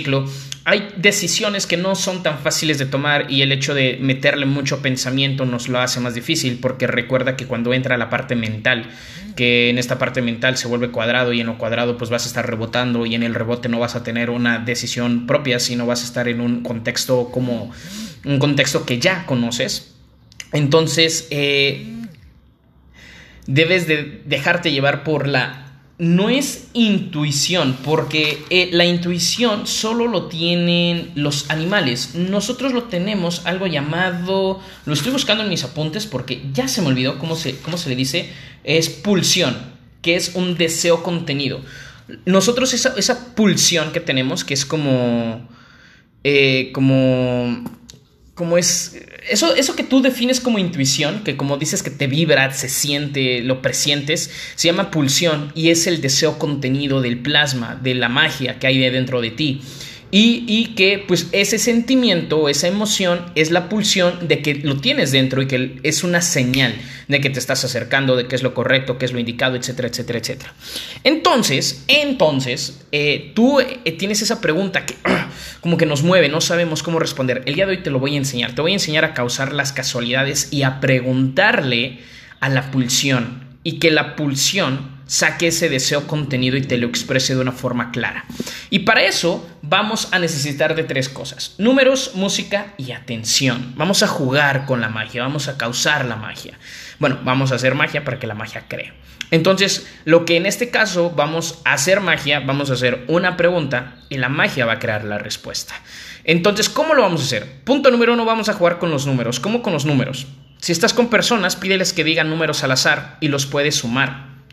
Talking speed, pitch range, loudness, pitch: 185 wpm, 130-175 Hz, -17 LUFS, 145 Hz